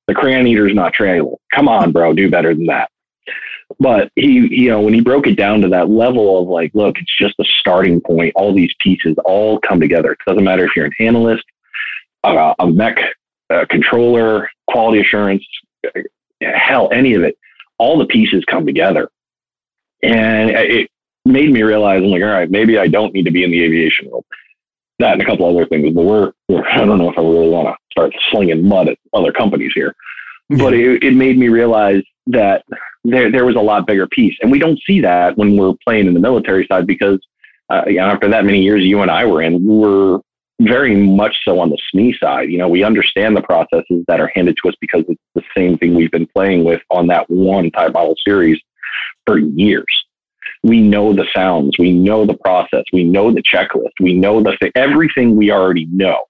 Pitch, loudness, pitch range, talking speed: 100 Hz, -12 LUFS, 90-115 Hz, 210 wpm